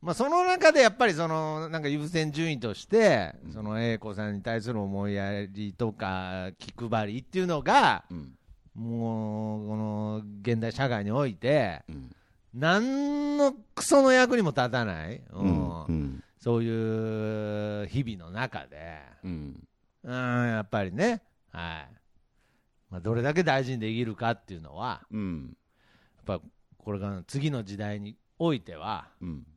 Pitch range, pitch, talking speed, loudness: 100-145 Hz, 115 Hz, 230 characters per minute, -28 LUFS